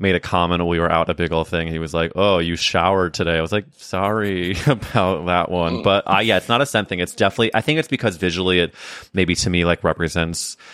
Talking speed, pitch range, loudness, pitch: 255 wpm, 85-100 Hz, -19 LUFS, 90 Hz